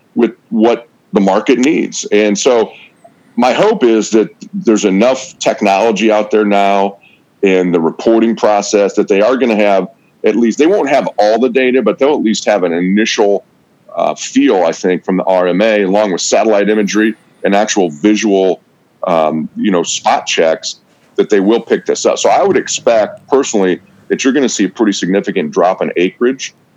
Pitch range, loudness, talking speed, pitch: 95-120 Hz, -12 LUFS, 185 wpm, 105 Hz